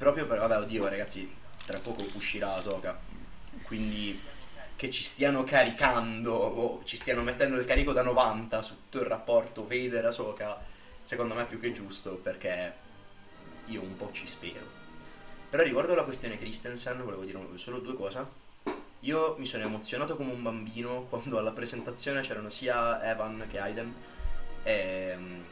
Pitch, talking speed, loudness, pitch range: 115 Hz, 160 wpm, -32 LUFS, 100-125 Hz